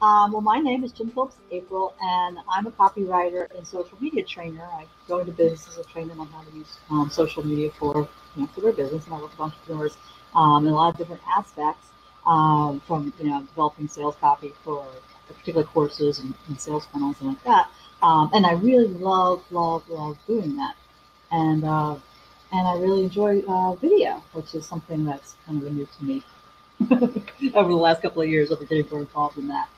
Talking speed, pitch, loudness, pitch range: 205 wpm, 165 Hz, -23 LUFS, 150-190 Hz